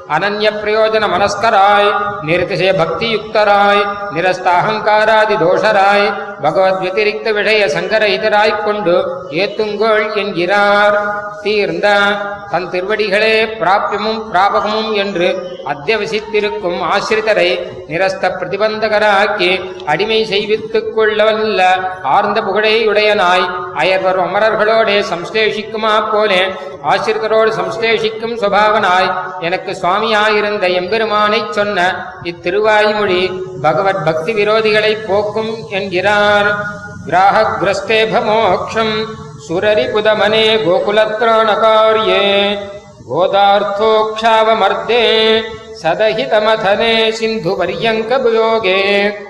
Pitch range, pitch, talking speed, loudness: 190-220 Hz, 205 Hz, 65 wpm, -13 LUFS